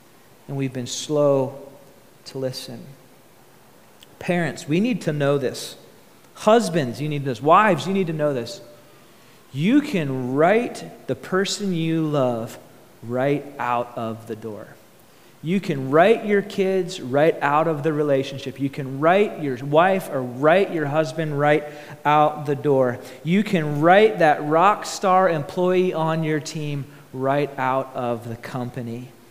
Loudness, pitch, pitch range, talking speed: -21 LUFS, 150 Hz, 130-170 Hz, 145 wpm